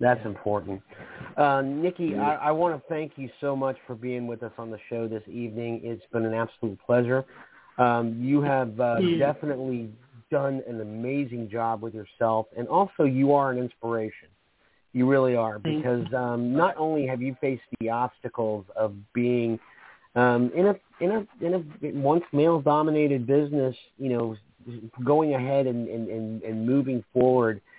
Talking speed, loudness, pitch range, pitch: 170 wpm, -26 LUFS, 115-140 Hz, 125 Hz